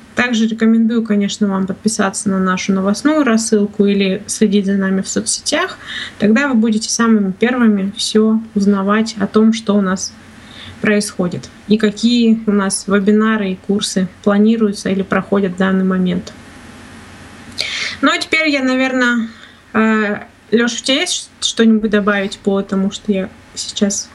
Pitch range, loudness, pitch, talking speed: 195-225 Hz, -15 LUFS, 210 Hz, 140 wpm